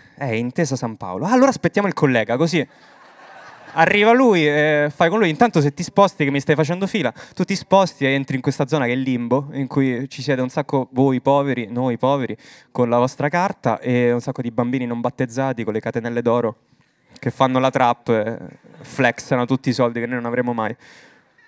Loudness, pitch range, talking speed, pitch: -19 LUFS, 120-155 Hz, 220 wpm, 135 Hz